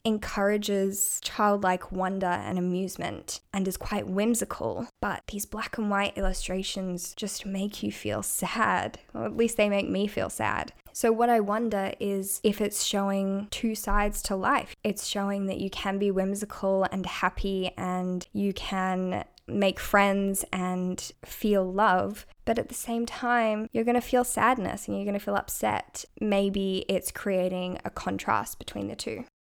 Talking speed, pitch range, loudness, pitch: 165 wpm, 190-210 Hz, -28 LUFS, 200 Hz